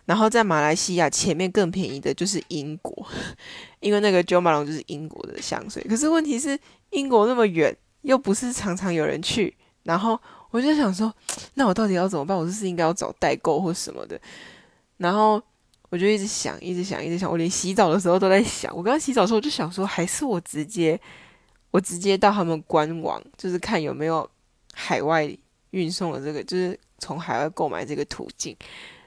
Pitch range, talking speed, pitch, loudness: 170-215 Hz, 305 characters per minute, 185 Hz, -23 LUFS